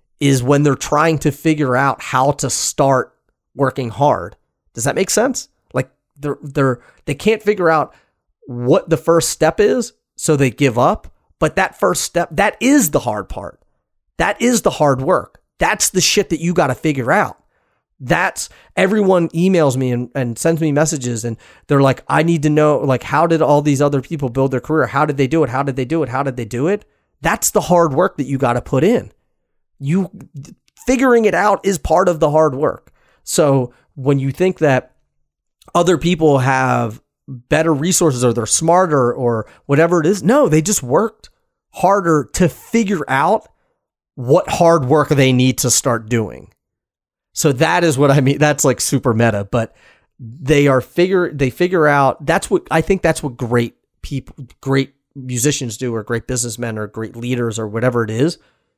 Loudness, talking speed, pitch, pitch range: -16 LUFS, 190 wpm, 145 Hz, 130-165 Hz